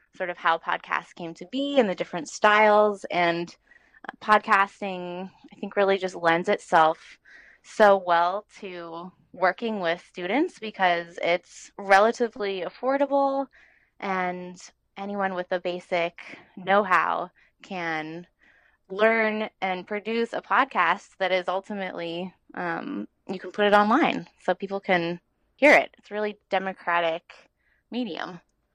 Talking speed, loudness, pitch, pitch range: 125 wpm, -24 LUFS, 190 Hz, 175-210 Hz